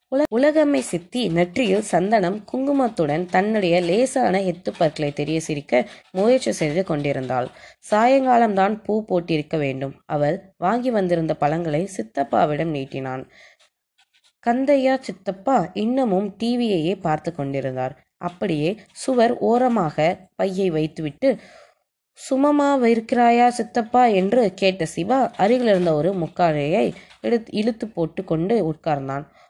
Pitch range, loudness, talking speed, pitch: 160-235 Hz, -21 LUFS, 100 wpm, 190 Hz